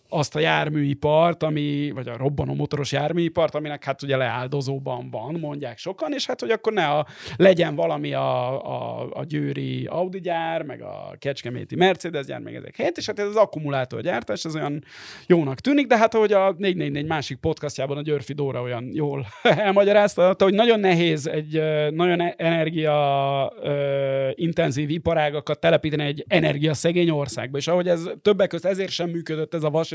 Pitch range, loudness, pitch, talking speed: 140-175 Hz, -23 LUFS, 155 Hz, 170 wpm